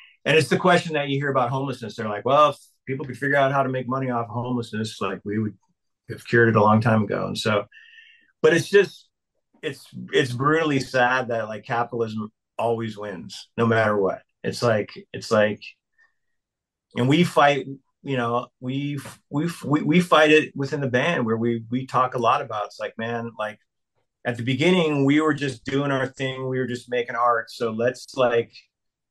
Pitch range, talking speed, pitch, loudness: 115-145 Hz, 200 wpm, 130 Hz, -22 LUFS